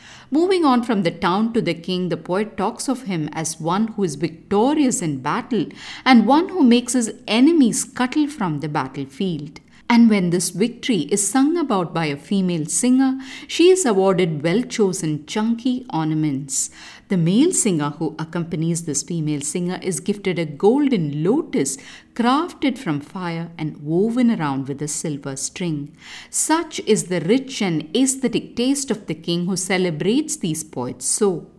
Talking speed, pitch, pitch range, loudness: 165 wpm, 195 Hz, 160-245 Hz, -20 LUFS